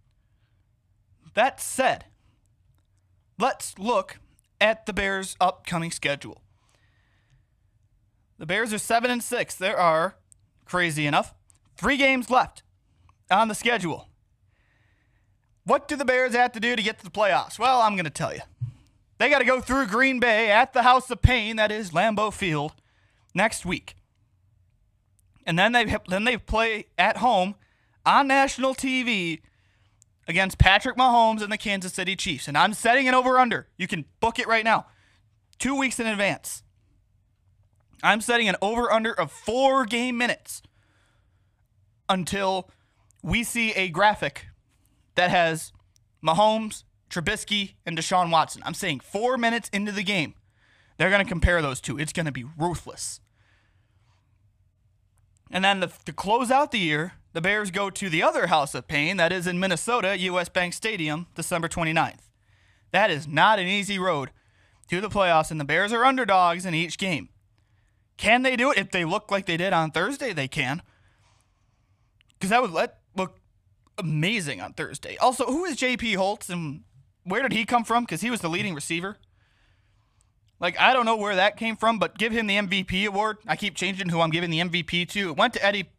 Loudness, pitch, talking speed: -24 LUFS, 175 Hz, 170 wpm